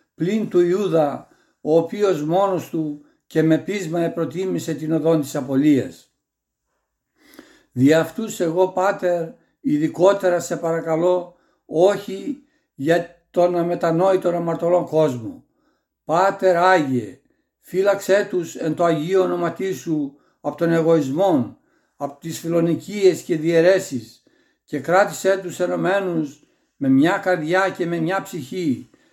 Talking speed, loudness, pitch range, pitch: 115 wpm, -20 LUFS, 160-190 Hz, 175 Hz